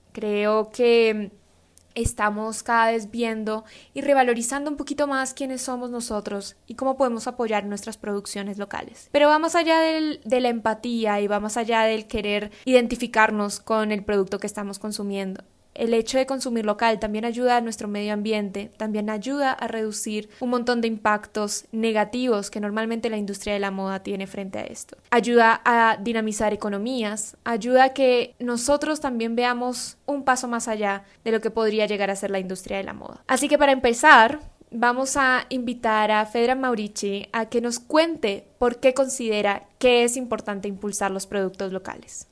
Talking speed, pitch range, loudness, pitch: 170 wpm, 210-250 Hz, -23 LUFS, 225 Hz